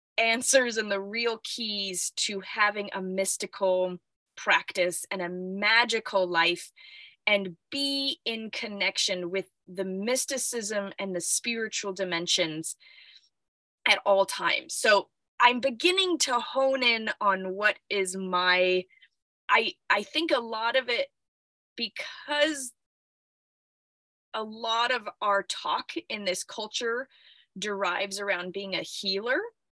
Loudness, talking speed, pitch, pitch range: -27 LUFS, 120 wpm, 210 Hz, 190-245 Hz